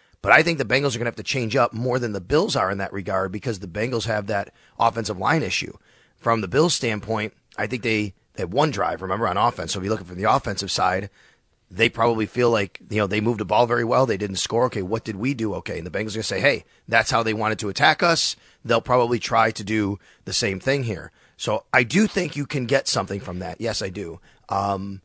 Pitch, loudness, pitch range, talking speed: 110 Hz, -22 LUFS, 100-120 Hz, 260 wpm